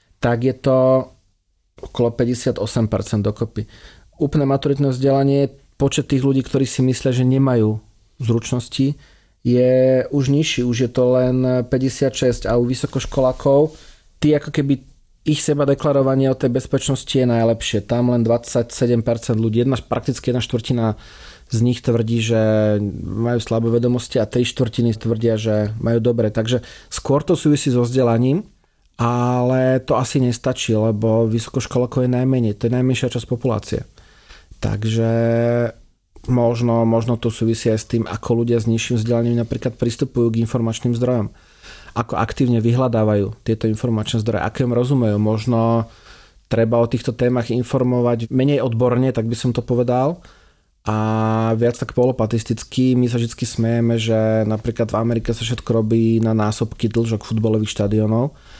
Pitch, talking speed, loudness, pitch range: 120 Hz, 145 wpm, -18 LUFS, 115-130 Hz